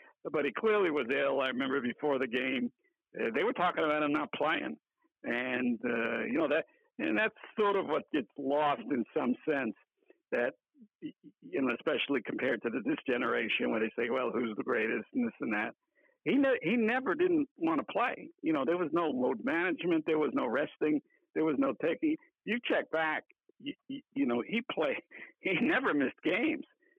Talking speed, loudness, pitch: 195 wpm, -32 LUFS, 270 Hz